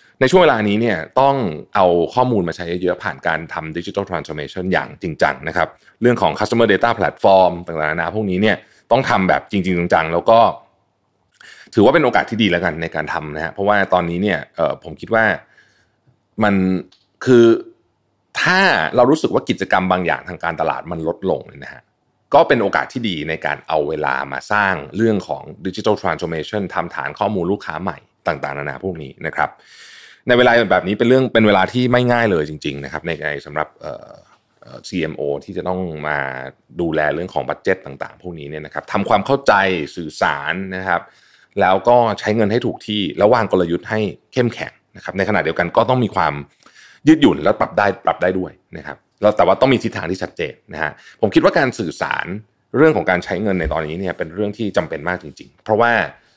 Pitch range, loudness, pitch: 80-105 Hz, -17 LUFS, 90 Hz